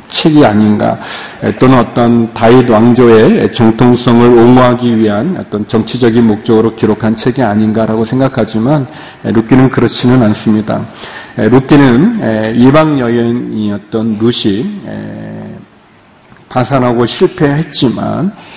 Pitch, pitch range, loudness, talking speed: 120 Hz, 110-130 Hz, -9 LUFS, 260 characters per minute